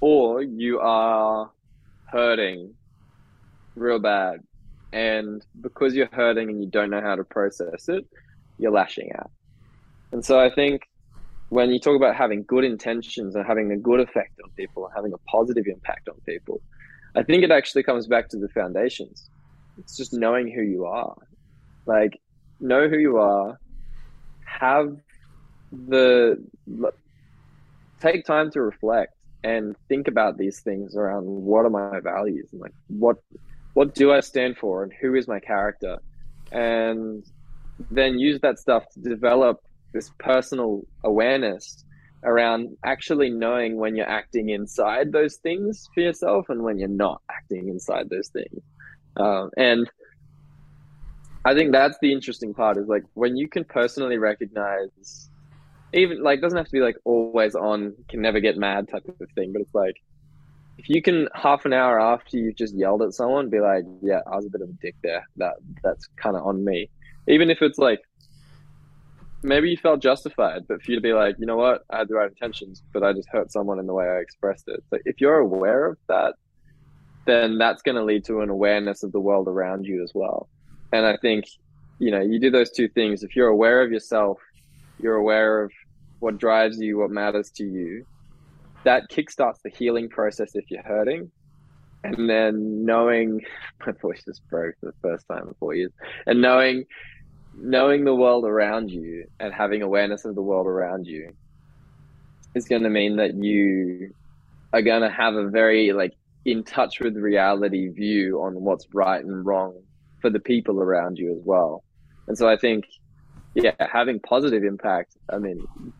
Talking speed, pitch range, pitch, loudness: 175 wpm, 105-135 Hz, 115 Hz, -22 LUFS